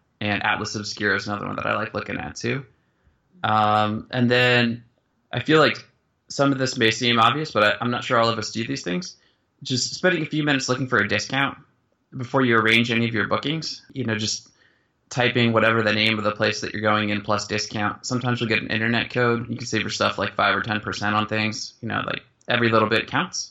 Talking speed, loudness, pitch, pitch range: 235 wpm, -22 LUFS, 115 Hz, 105-125 Hz